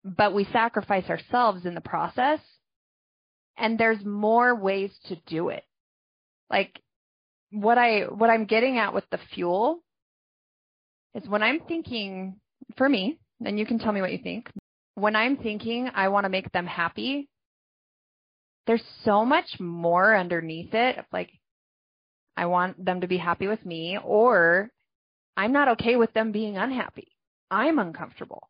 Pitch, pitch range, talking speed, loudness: 210 Hz, 185-235 Hz, 155 wpm, -25 LUFS